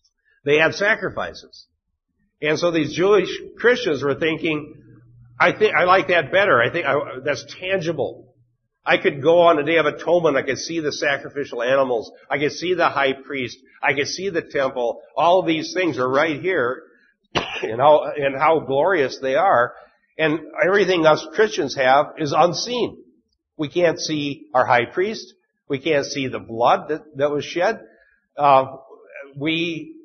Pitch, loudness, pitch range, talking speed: 150 Hz, -20 LUFS, 140-170 Hz, 165 wpm